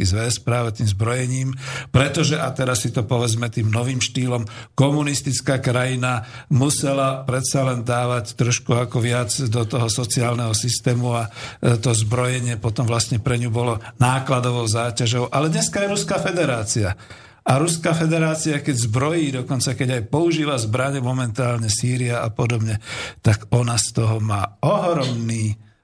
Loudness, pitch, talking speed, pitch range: -20 LUFS, 125 Hz, 145 wpm, 115-135 Hz